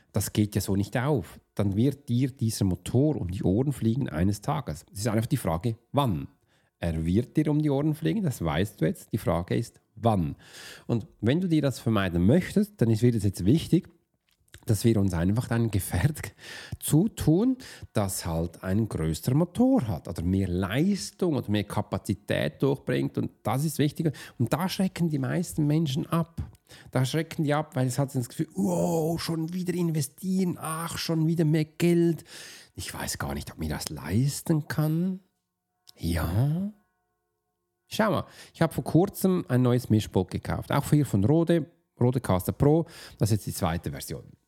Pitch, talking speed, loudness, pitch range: 130 Hz, 175 wpm, -27 LUFS, 100-160 Hz